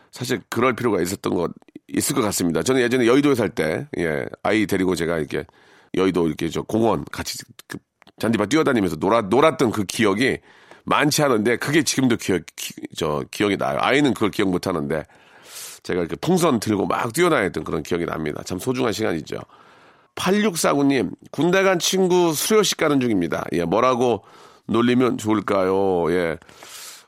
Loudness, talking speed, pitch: -21 LUFS, 345 characters per minute, 120 Hz